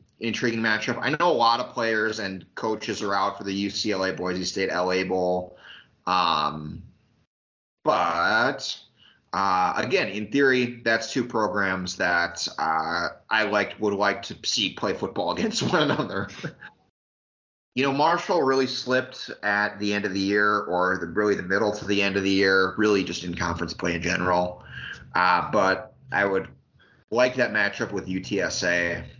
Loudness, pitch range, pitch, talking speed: -24 LUFS, 90-110 Hz, 100 Hz, 160 wpm